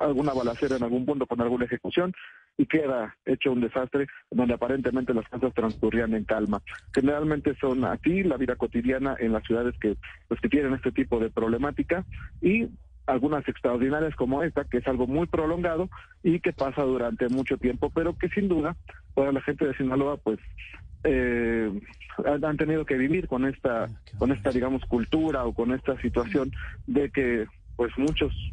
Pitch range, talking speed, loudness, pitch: 120-145 Hz, 170 wpm, -27 LUFS, 130 Hz